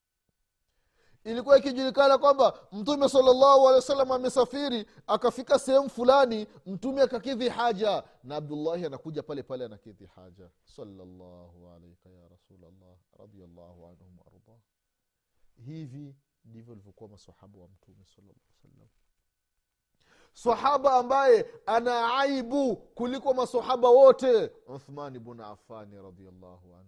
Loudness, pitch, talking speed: -24 LUFS, 150 Hz, 85 wpm